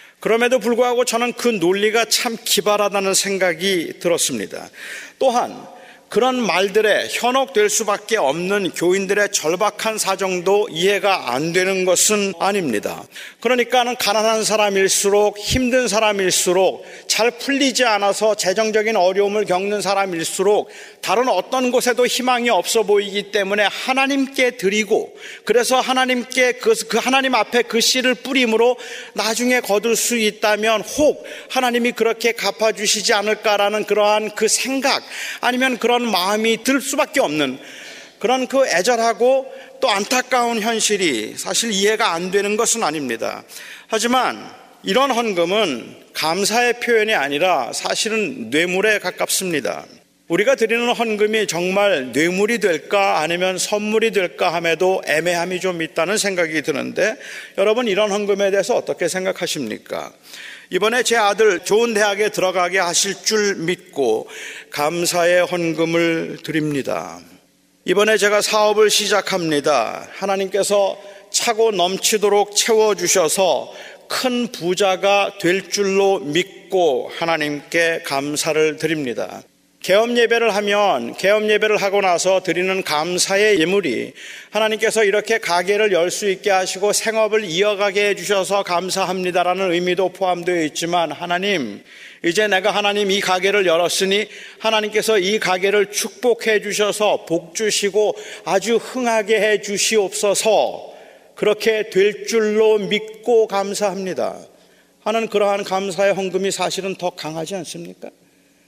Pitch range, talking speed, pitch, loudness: 185-225 Hz, 305 characters per minute, 205 Hz, -18 LUFS